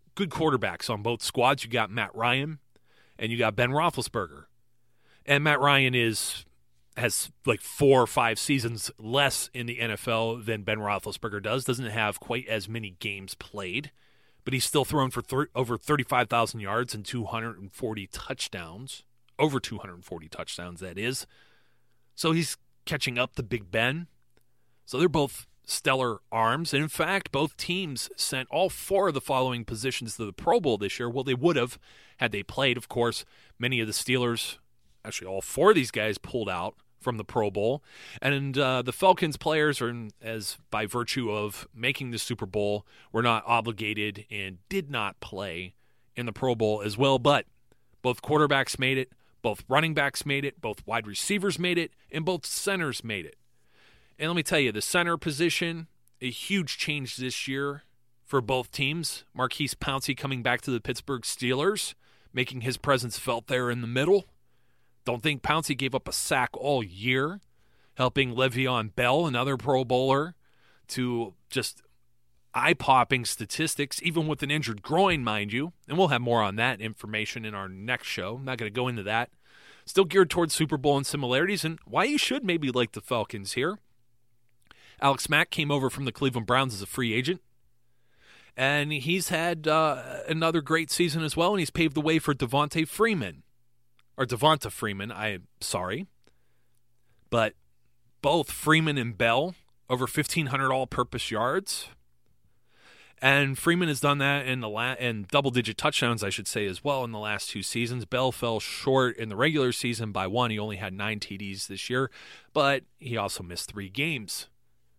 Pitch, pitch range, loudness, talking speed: 125 Hz, 115-145 Hz, -27 LUFS, 175 wpm